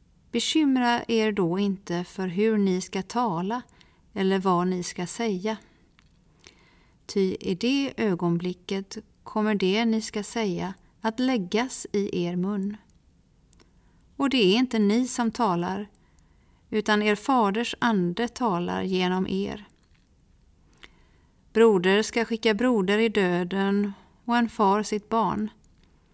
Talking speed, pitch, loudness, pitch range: 120 wpm, 210 Hz, -25 LUFS, 190-230 Hz